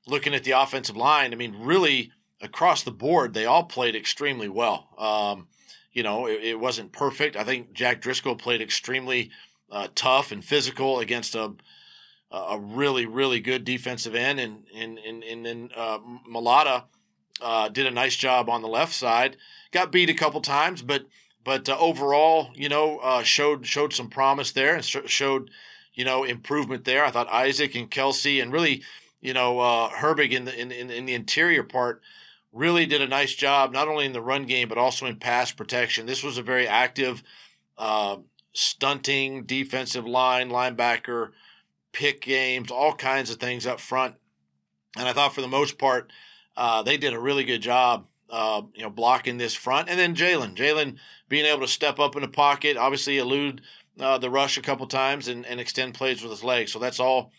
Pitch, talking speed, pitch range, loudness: 130 Hz, 190 wpm, 120-140 Hz, -24 LUFS